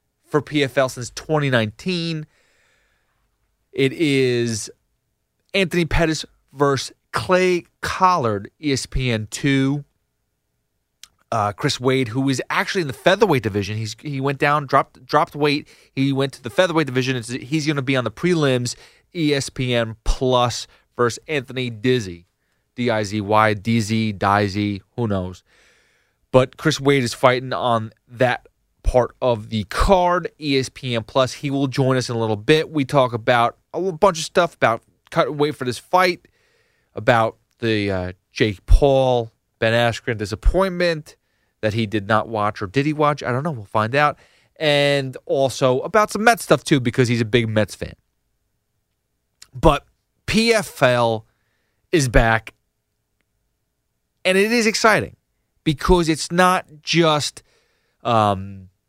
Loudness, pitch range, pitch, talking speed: -20 LUFS, 115-150 Hz, 130 Hz, 140 wpm